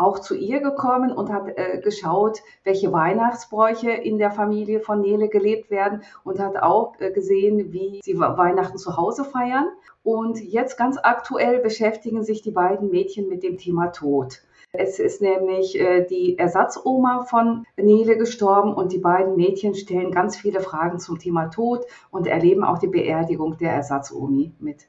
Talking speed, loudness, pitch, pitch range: 165 wpm, -21 LUFS, 195 Hz, 180-225 Hz